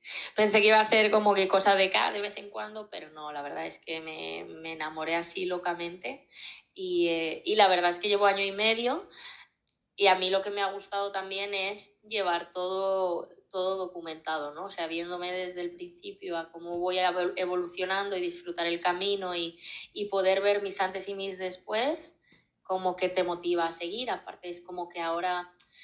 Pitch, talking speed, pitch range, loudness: 185 Hz, 200 wpm, 175-200 Hz, -28 LUFS